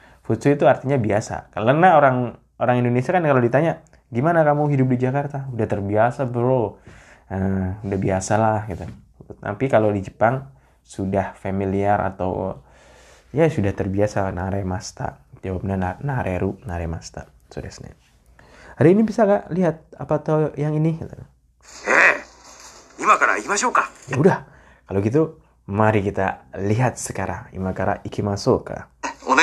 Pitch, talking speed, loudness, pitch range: 110 Hz, 130 wpm, -21 LUFS, 95-135 Hz